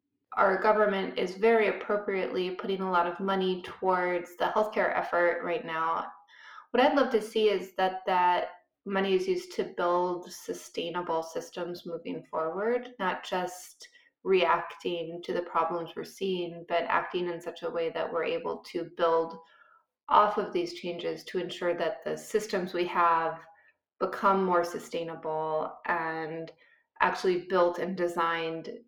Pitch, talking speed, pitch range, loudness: 180 Hz, 150 wpm, 170-210 Hz, -29 LUFS